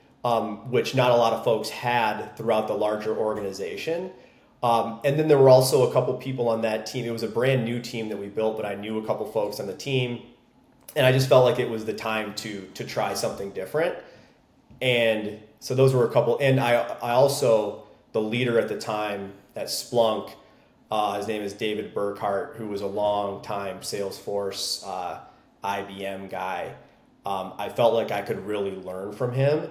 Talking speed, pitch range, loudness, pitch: 200 wpm, 100-125 Hz, -25 LUFS, 110 Hz